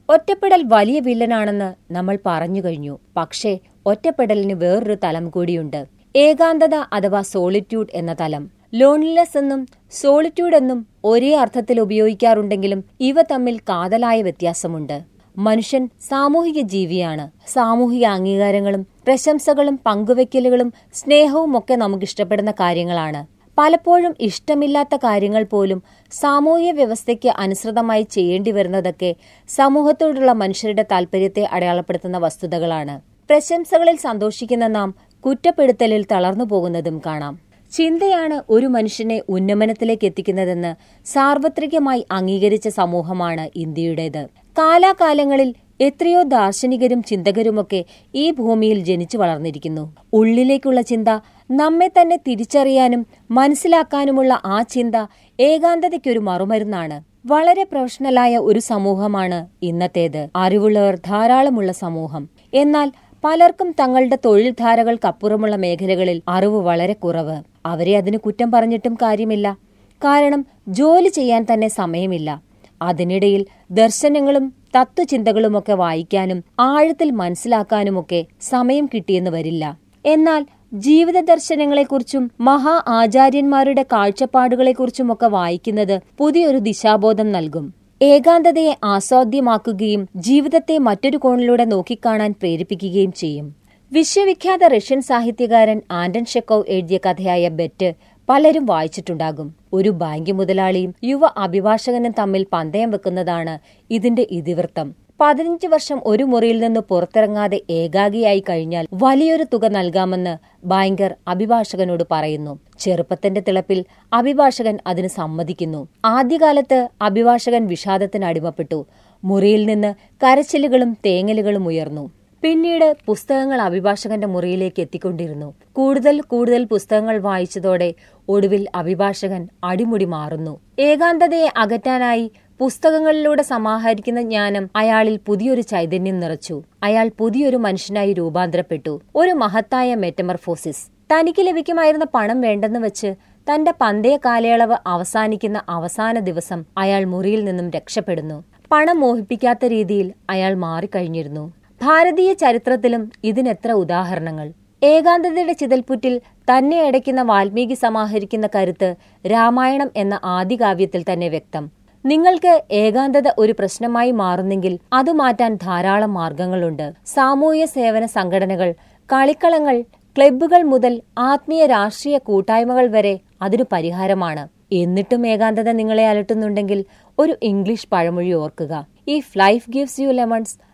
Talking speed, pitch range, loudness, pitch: 95 wpm, 185-265 Hz, -17 LUFS, 220 Hz